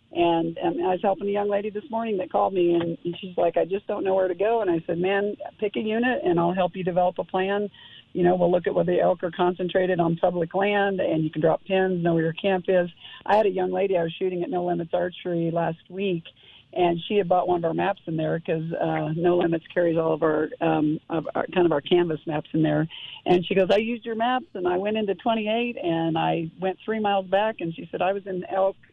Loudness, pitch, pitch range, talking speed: -24 LUFS, 180 Hz, 170-195 Hz, 265 wpm